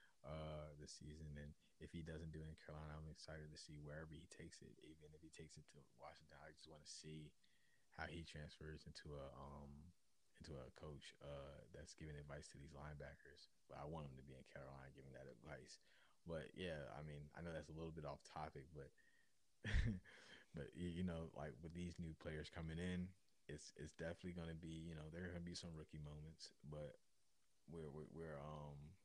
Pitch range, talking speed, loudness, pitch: 75-80 Hz, 210 wpm, -55 LUFS, 75 Hz